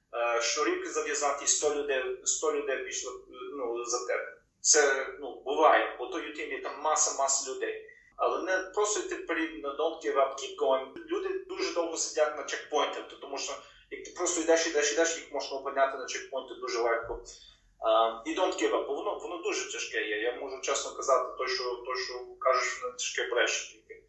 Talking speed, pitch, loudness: 175 wpm, 370 Hz, -30 LUFS